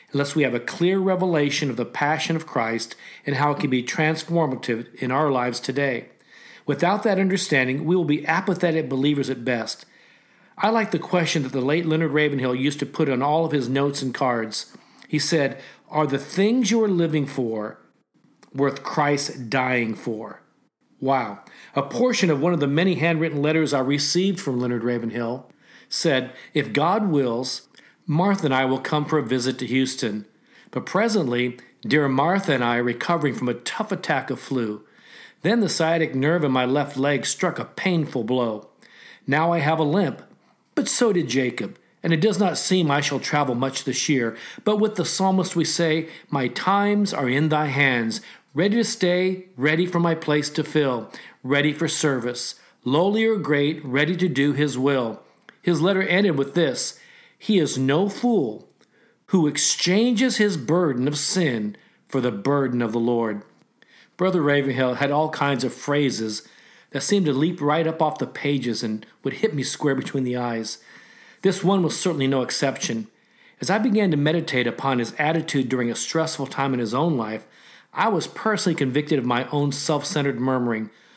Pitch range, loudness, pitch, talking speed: 130-170 Hz, -22 LUFS, 145 Hz, 185 wpm